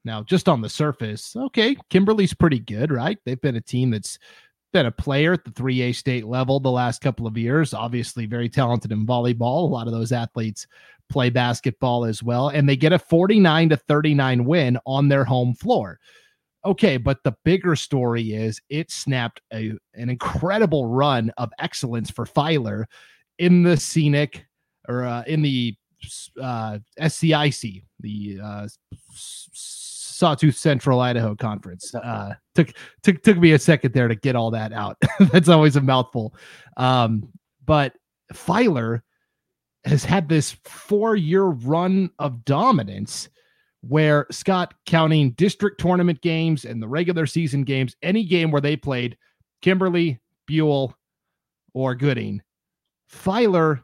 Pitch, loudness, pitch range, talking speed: 135 Hz, -21 LUFS, 120-165 Hz, 150 wpm